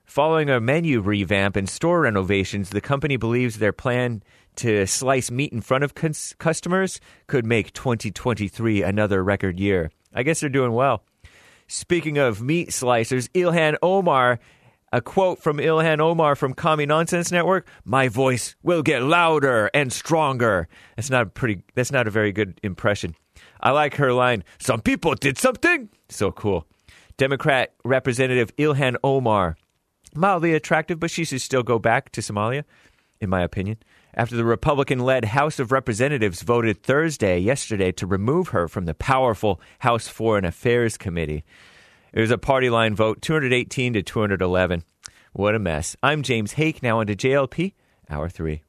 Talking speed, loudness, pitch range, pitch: 165 wpm, -21 LUFS, 105-145 Hz, 125 Hz